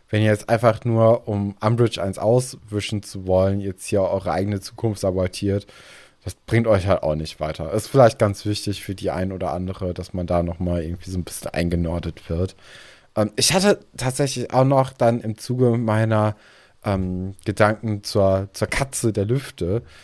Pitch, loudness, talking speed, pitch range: 105 Hz, -22 LUFS, 180 wpm, 95-115 Hz